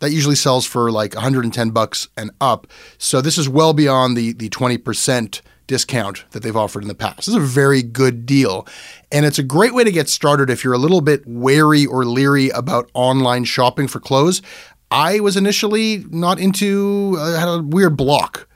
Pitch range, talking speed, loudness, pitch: 125-165 Hz, 195 wpm, -16 LUFS, 135 Hz